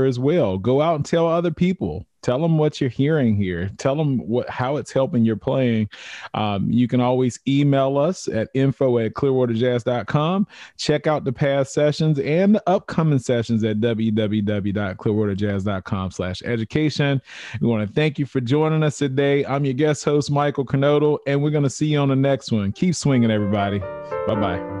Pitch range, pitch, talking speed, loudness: 110-150 Hz, 135 Hz, 175 wpm, -21 LUFS